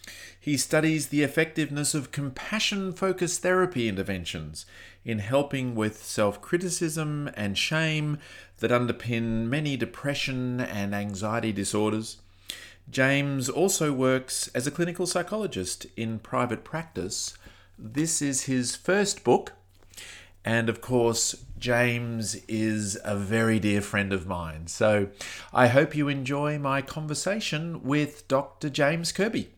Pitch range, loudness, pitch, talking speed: 105-150 Hz, -27 LUFS, 125 Hz, 120 wpm